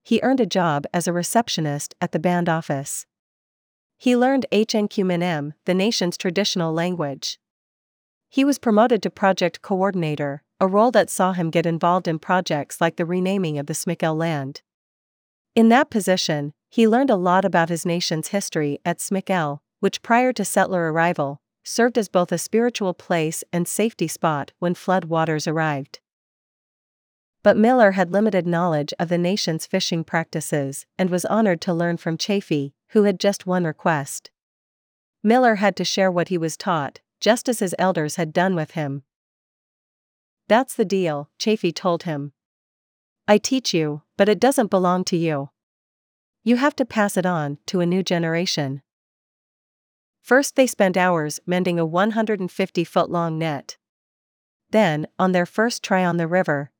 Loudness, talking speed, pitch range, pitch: -21 LUFS, 160 wpm, 165-205 Hz, 180 Hz